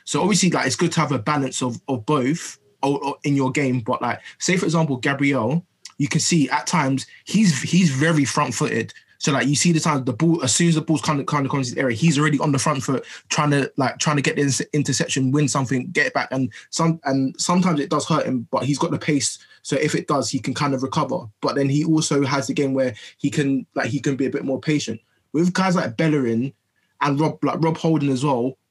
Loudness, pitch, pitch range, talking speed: -21 LUFS, 145 Hz, 135-155 Hz, 250 wpm